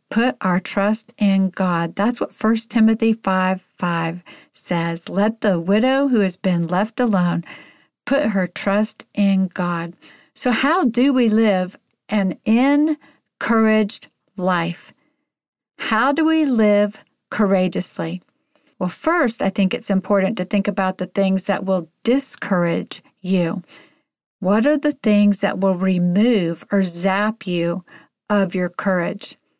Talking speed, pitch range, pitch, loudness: 135 wpm, 185-225 Hz, 200 Hz, -19 LUFS